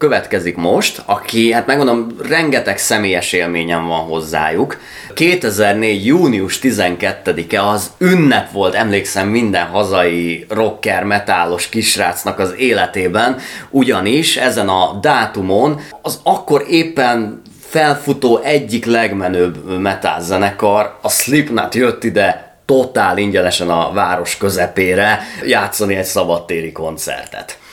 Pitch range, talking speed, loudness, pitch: 90-115 Hz, 105 wpm, -14 LUFS, 100 Hz